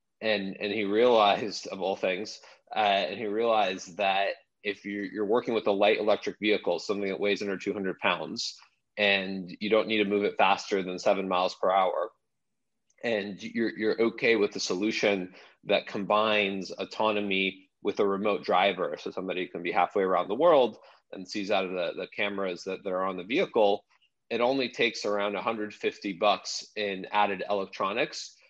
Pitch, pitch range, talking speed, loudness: 100 Hz, 95-105 Hz, 175 wpm, -28 LUFS